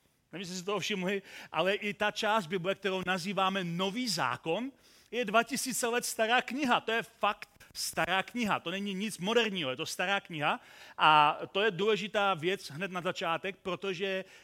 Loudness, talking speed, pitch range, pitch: -31 LUFS, 170 wpm, 180-215 Hz, 195 Hz